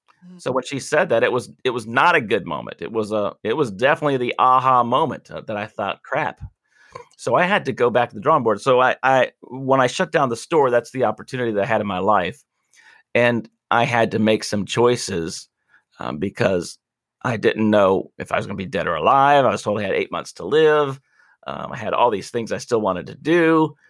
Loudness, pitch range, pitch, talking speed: -20 LUFS, 110-145 Hz, 125 Hz, 240 wpm